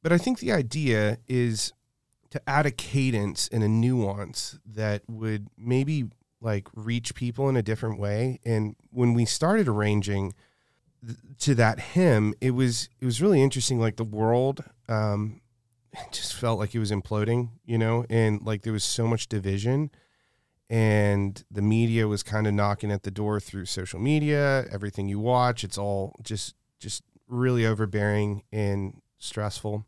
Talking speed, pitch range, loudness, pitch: 165 wpm, 105-125 Hz, -26 LUFS, 115 Hz